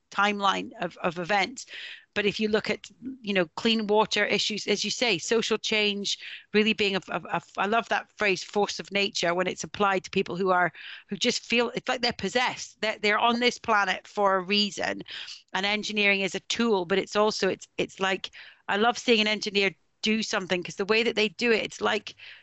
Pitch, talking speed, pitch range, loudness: 205 Hz, 215 wpm, 195-220 Hz, -26 LUFS